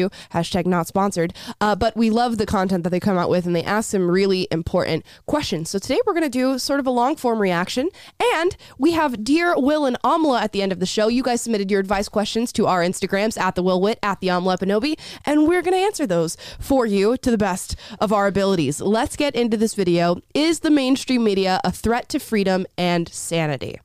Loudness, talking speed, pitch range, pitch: -20 LUFS, 230 wpm, 185-260 Hz, 210 Hz